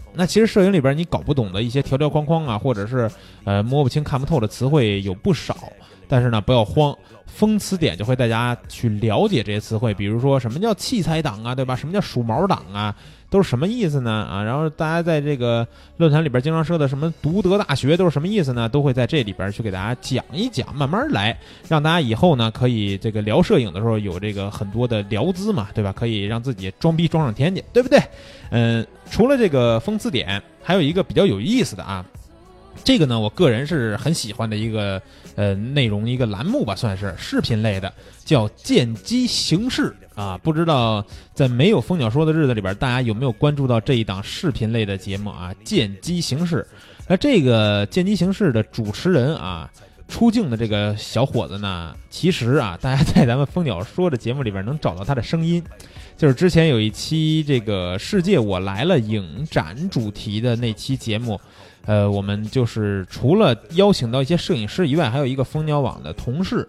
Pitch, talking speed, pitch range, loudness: 125 Hz, 315 characters per minute, 105-160 Hz, -20 LUFS